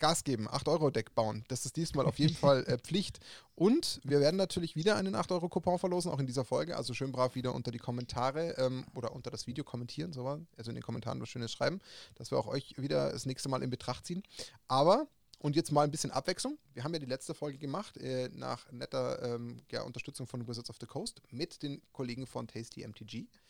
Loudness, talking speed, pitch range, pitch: -35 LUFS, 230 wpm, 125-165 Hz, 135 Hz